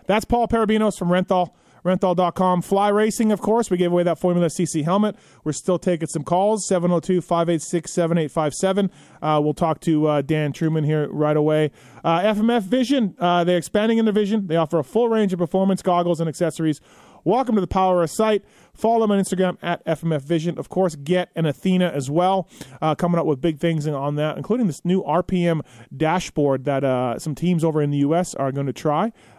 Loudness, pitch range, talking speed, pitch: -21 LUFS, 155-190 Hz, 200 wpm, 175 Hz